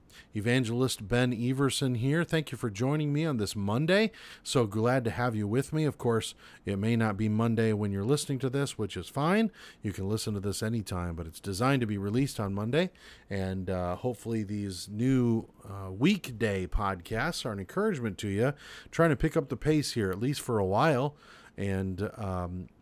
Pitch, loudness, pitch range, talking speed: 115 Hz, -30 LUFS, 100-135 Hz, 200 wpm